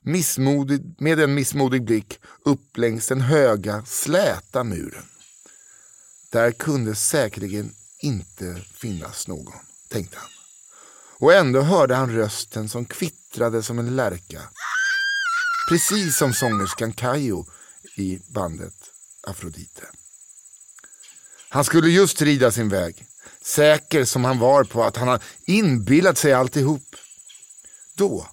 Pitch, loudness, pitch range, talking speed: 130 Hz, -20 LUFS, 115-150 Hz, 115 wpm